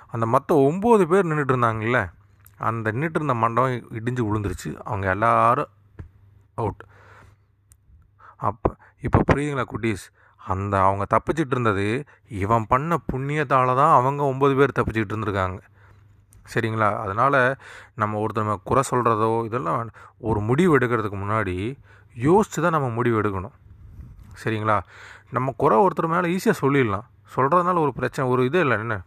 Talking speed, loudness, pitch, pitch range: 125 wpm, -22 LUFS, 115 Hz, 100-135 Hz